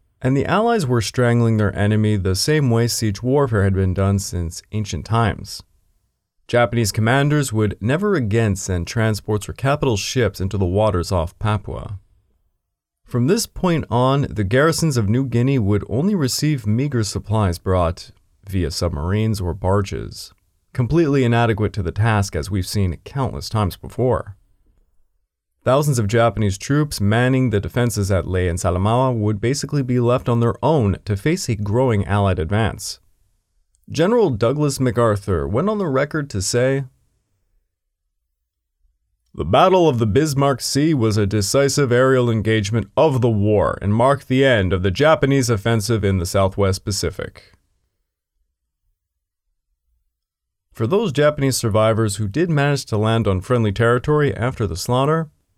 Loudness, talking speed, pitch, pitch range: -19 LUFS, 150 wpm, 105 Hz, 95-125 Hz